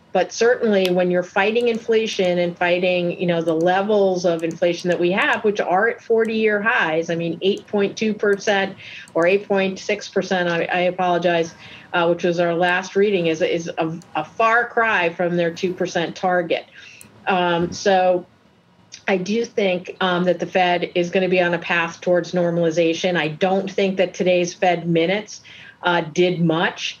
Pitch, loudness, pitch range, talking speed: 180 Hz, -20 LUFS, 175-195 Hz, 170 wpm